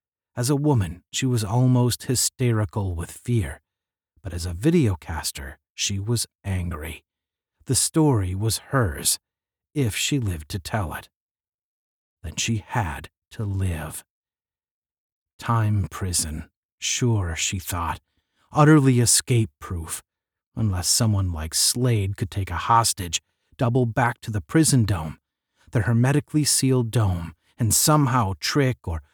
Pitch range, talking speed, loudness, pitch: 85-125 Hz, 125 wpm, -23 LUFS, 105 Hz